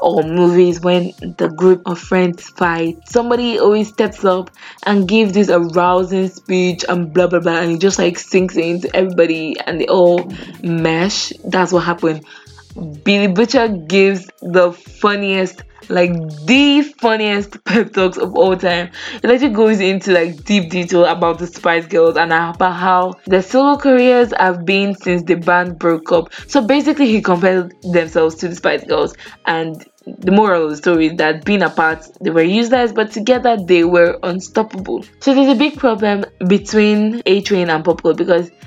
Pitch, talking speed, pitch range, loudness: 185 Hz, 170 wpm, 175-210 Hz, -14 LUFS